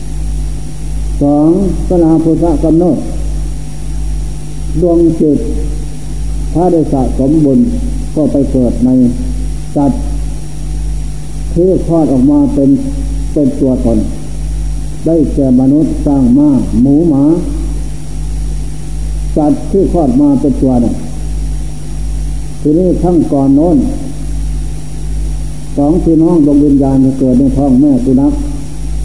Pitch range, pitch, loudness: 140-160 Hz, 150 Hz, -11 LUFS